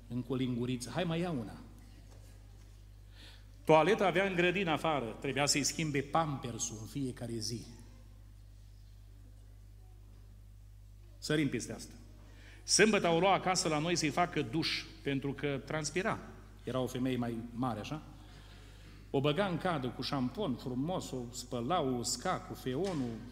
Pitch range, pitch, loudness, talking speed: 100-150 Hz, 120 Hz, -34 LUFS, 135 wpm